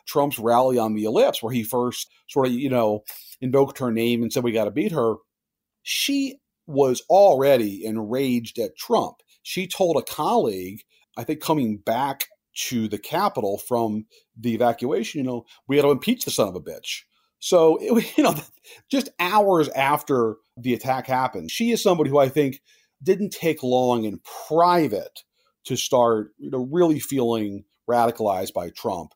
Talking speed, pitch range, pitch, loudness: 175 wpm, 115-160 Hz, 130 Hz, -22 LUFS